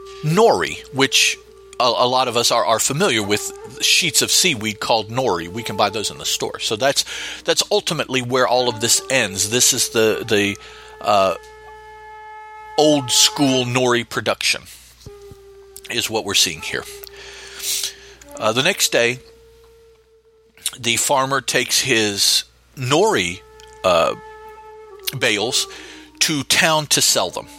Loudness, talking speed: -17 LUFS, 135 wpm